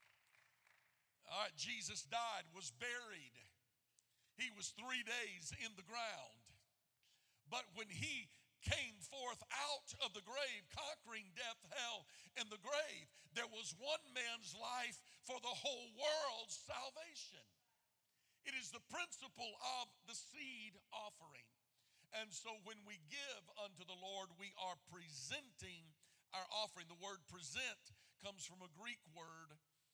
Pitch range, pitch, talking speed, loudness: 180-245 Hz, 215 Hz, 135 wpm, -48 LUFS